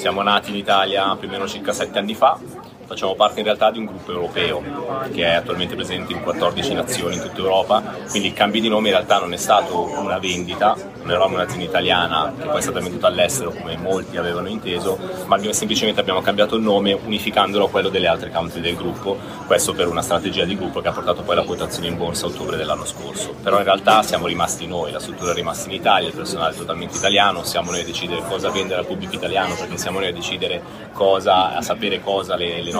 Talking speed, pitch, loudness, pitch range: 230 wpm, 95 Hz, -20 LUFS, 90-100 Hz